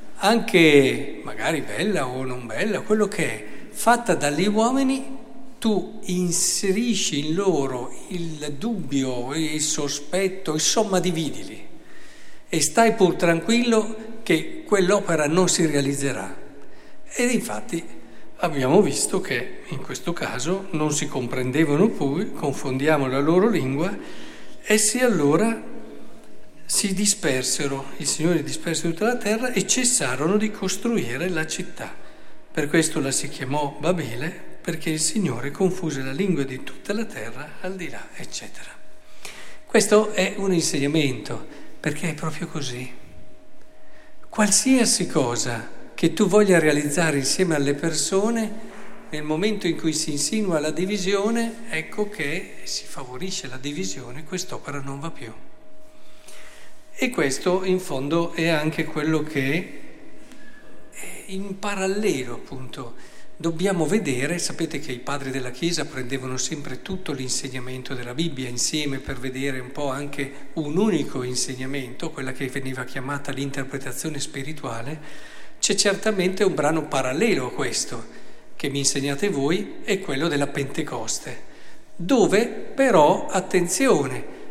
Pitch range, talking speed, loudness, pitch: 140-200 Hz, 125 wpm, -23 LUFS, 160 Hz